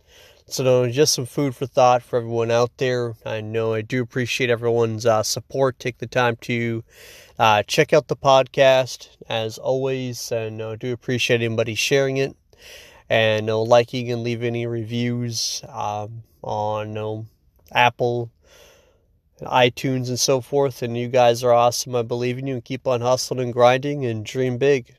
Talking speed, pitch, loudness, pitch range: 175 wpm, 120 Hz, -21 LUFS, 115-130 Hz